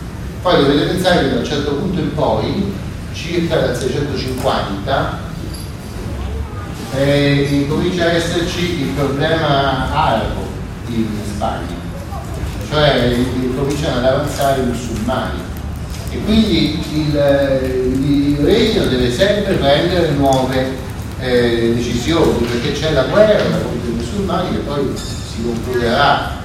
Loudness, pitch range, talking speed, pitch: -16 LUFS, 110-145 Hz, 115 wpm, 130 Hz